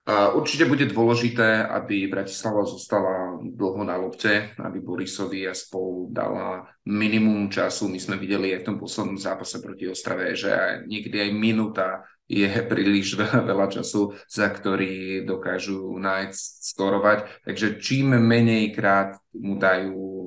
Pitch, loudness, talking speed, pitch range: 100 Hz, -24 LUFS, 135 wpm, 95-110 Hz